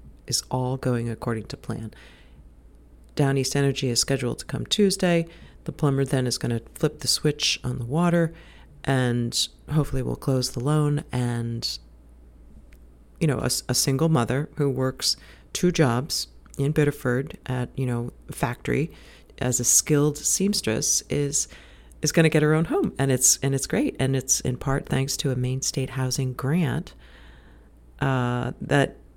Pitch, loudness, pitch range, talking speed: 130 Hz, -24 LUFS, 115-145 Hz, 165 wpm